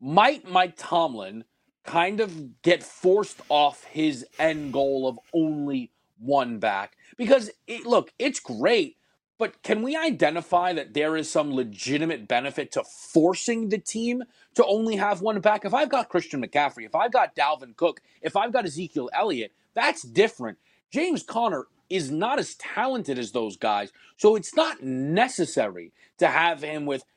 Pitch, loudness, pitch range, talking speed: 170 Hz, -25 LUFS, 145-220 Hz, 160 wpm